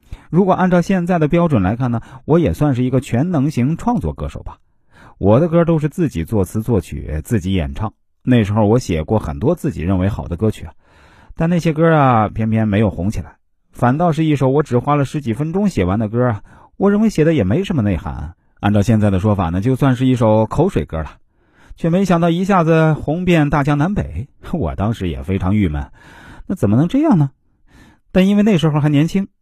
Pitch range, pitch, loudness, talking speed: 100-160 Hz, 125 Hz, -16 LUFS, 310 characters per minute